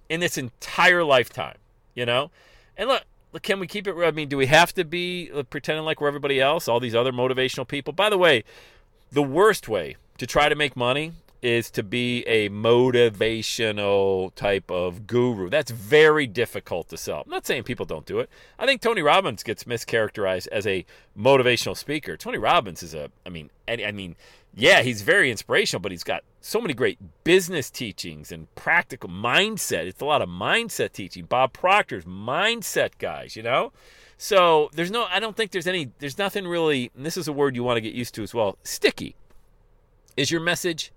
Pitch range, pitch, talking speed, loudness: 115-165 Hz, 135 Hz, 195 wpm, -23 LUFS